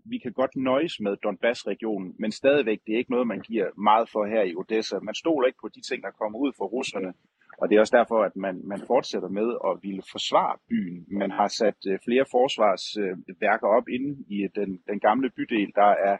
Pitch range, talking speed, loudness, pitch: 100-130 Hz, 220 wpm, -25 LUFS, 110 Hz